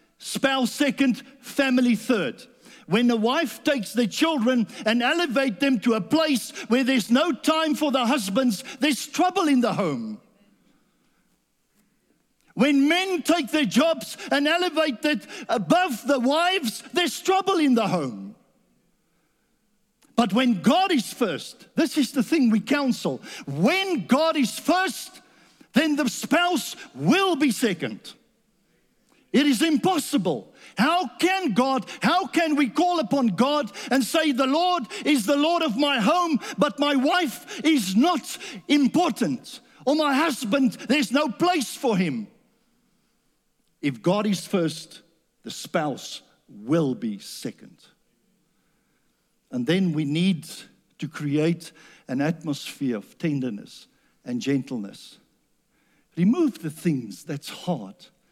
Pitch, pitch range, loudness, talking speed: 255 Hz, 220-295 Hz, -23 LUFS, 130 wpm